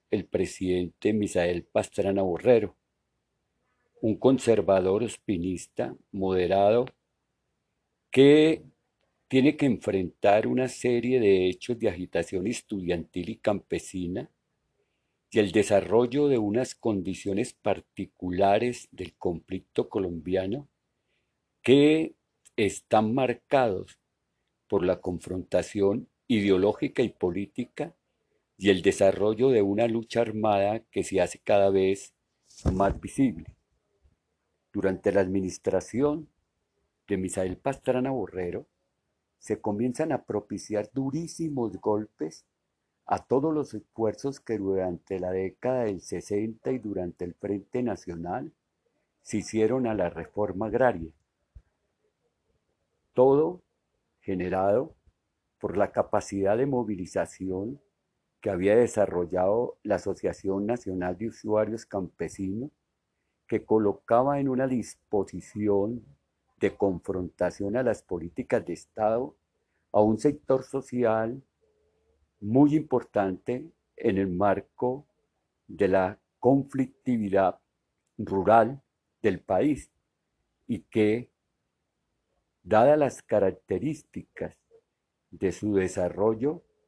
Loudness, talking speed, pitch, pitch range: -27 LUFS, 95 wpm, 100 Hz, 95-125 Hz